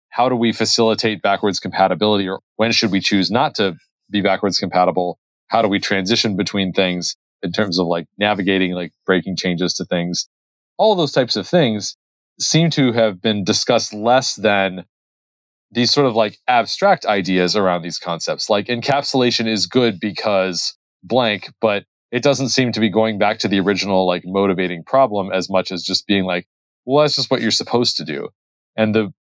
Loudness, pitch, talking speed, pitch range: -18 LUFS, 100 Hz, 185 wpm, 95-115 Hz